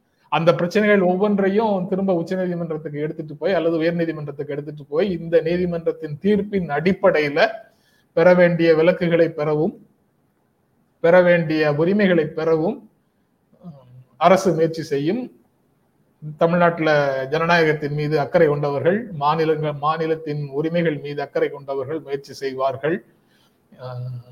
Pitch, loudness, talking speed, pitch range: 160 Hz, -20 LUFS, 100 wpm, 150-175 Hz